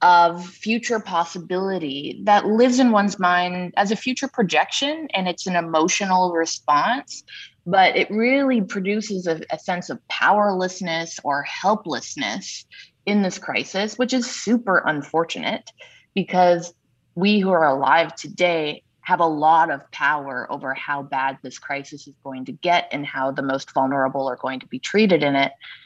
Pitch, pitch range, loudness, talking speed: 180 Hz, 155-205 Hz, -21 LUFS, 155 wpm